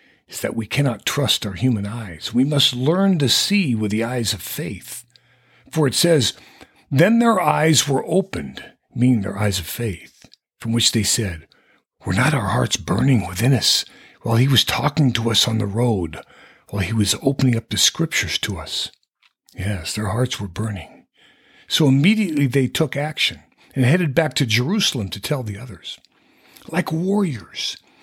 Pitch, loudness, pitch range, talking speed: 125 Hz, -19 LUFS, 105-145 Hz, 175 wpm